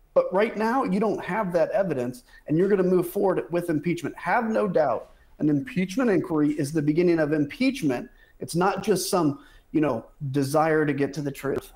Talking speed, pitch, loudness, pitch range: 200 wpm, 170 Hz, -25 LUFS, 150-200 Hz